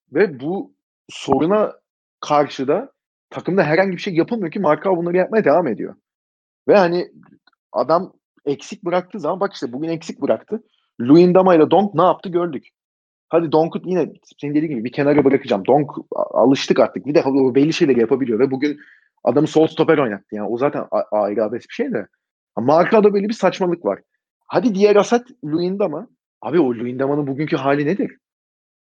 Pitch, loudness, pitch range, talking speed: 165 Hz, -18 LUFS, 145-190 Hz, 170 wpm